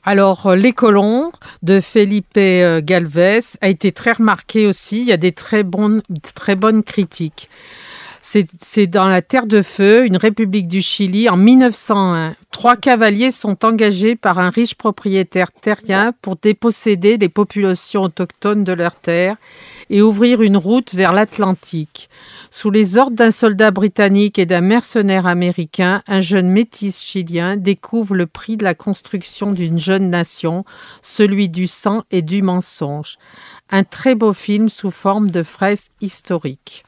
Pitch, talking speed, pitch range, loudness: 200 Hz, 155 wpm, 185-220 Hz, -14 LUFS